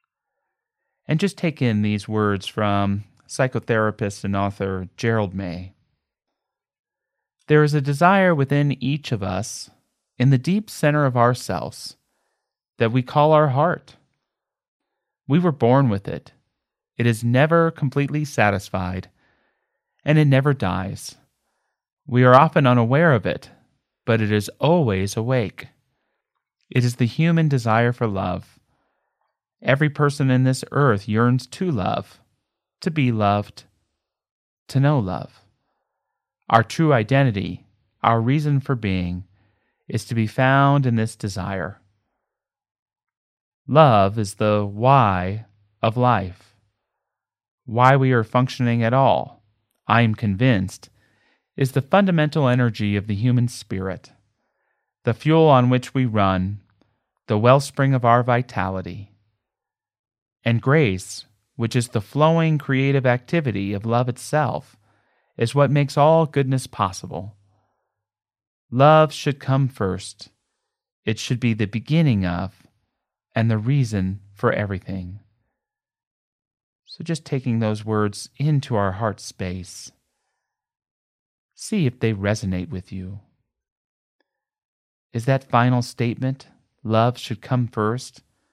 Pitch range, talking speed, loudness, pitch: 105-135 Hz, 120 wpm, -20 LUFS, 120 Hz